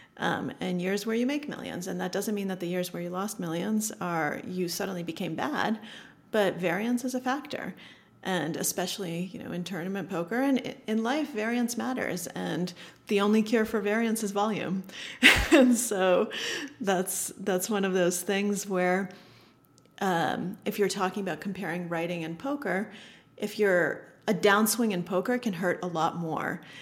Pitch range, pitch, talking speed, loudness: 180-225 Hz, 195 Hz, 180 wpm, -28 LUFS